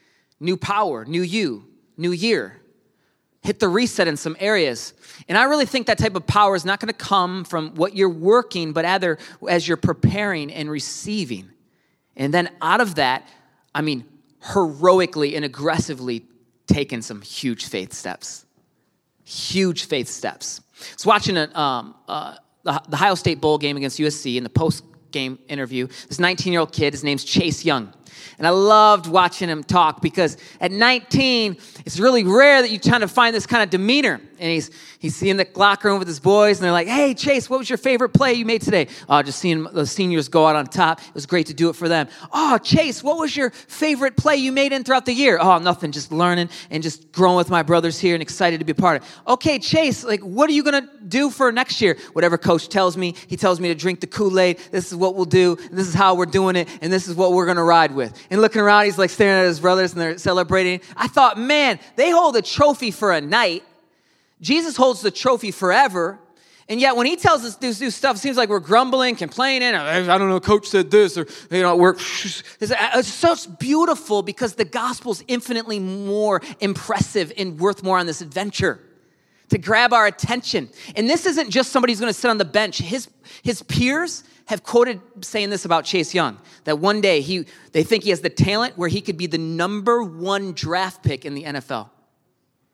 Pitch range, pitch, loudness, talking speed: 165-225 Hz, 185 Hz, -19 LUFS, 215 wpm